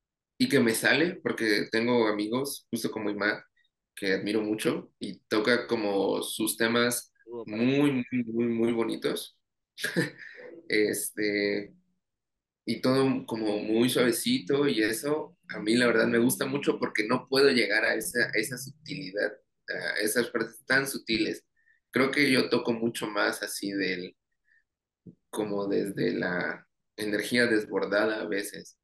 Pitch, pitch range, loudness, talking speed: 115 Hz, 105-135 Hz, -28 LUFS, 140 wpm